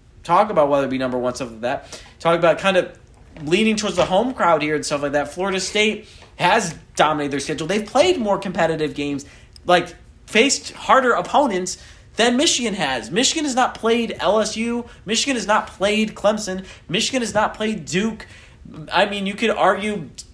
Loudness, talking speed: -19 LUFS, 185 wpm